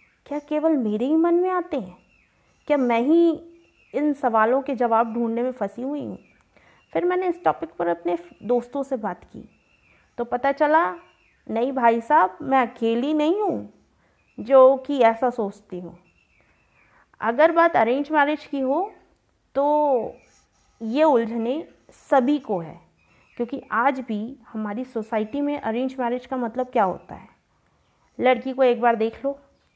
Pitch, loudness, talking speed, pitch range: 260 Hz, -22 LUFS, 155 wpm, 230-290 Hz